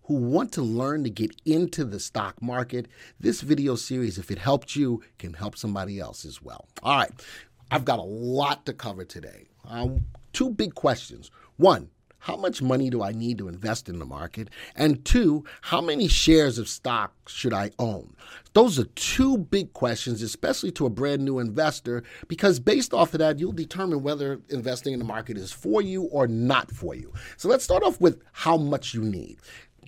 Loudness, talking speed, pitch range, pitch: -25 LUFS, 195 wpm, 115-150 Hz, 125 Hz